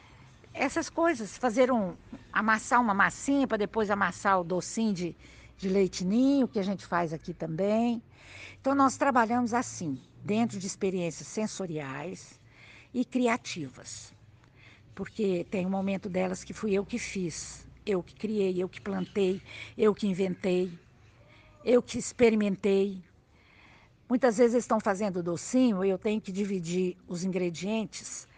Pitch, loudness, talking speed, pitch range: 195 Hz, -29 LUFS, 140 wpm, 175-225 Hz